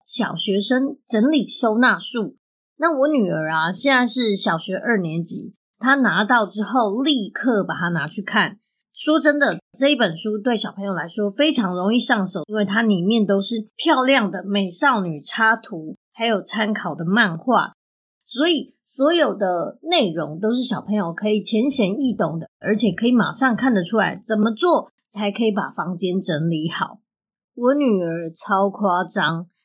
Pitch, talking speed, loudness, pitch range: 215 Hz, 245 characters per minute, -20 LUFS, 190-245 Hz